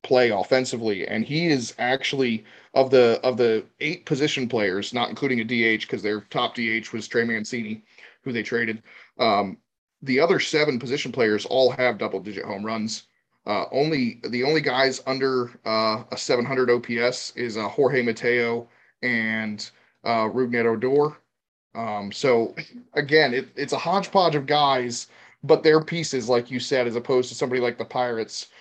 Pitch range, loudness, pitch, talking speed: 115-135 Hz, -23 LUFS, 125 Hz, 165 wpm